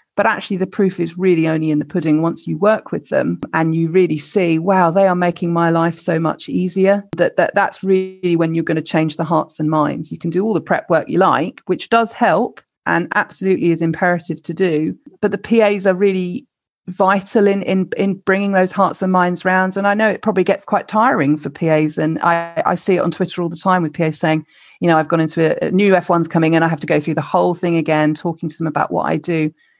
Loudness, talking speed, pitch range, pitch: -16 LUFS, 250 wpm, 160-190 Hz, 175 Hz